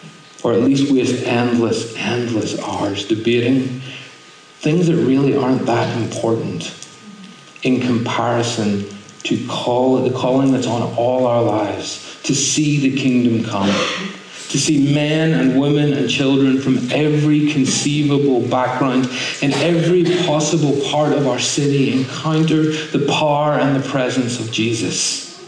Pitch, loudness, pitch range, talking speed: 130 Hz, -17 LUFS, 120-145 Hz, 130 wpm